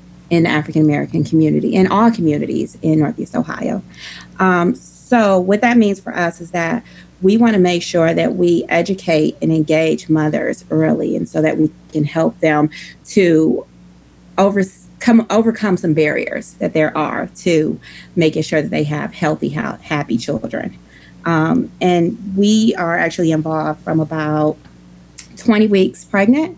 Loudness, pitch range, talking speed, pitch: -16 LUFS, 155-190 Hz, 150 wpm, 165 Hz